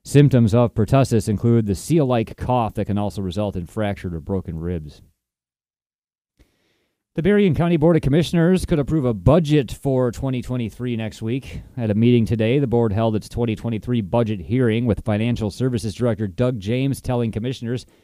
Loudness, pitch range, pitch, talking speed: -20 LUFS, 105-130 Hz, 120 Hz, 165 wpm